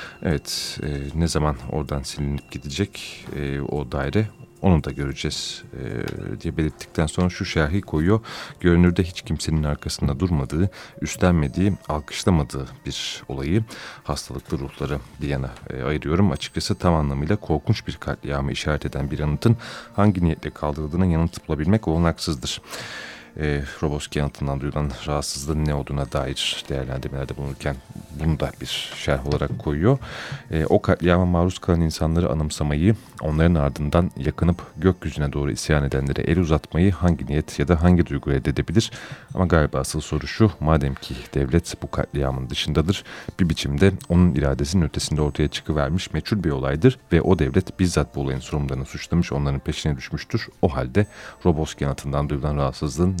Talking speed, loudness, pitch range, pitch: 145 wpm, -23 LUFS, 70-90 Hz, 75 Hz